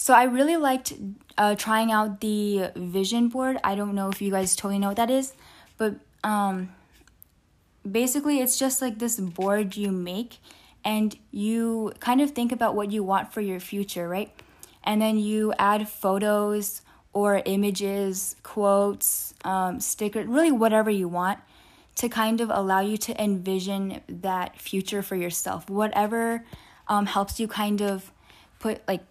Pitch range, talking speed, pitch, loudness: 195-225 Hz, 160 wpm, 205 Hz, -25 LUFS